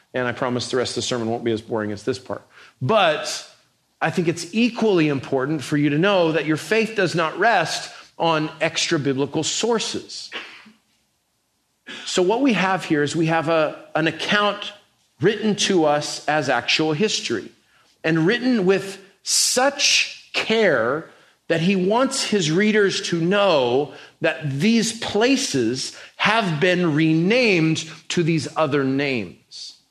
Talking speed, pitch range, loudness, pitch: 150 wpm, 150-205 Hz, -20 LUFS, 165 Hz